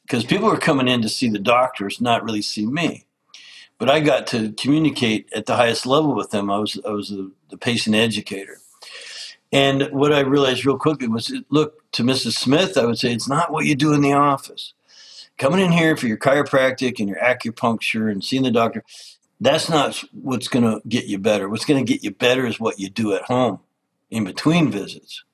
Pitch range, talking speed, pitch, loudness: 110-140 Hz, 215 wpm, 125 Hz, -19 LUFS